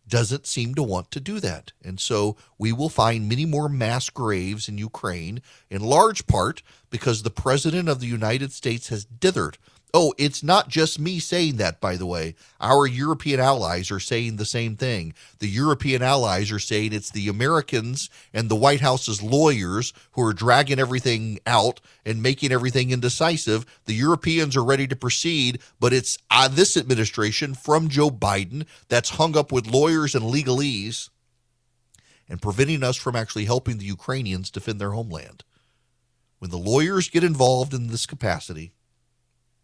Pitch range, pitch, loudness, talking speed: 110-140 Hz, 120 Hz, -22 LUFS, 165 wpm